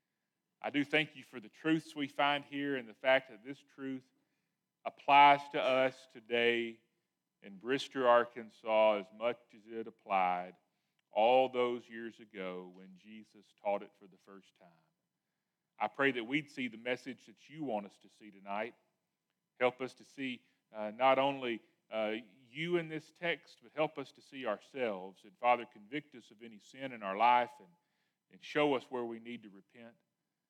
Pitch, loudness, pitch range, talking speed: 120 Hz, -34 LUFS, 110-140 Hz, 180 wpm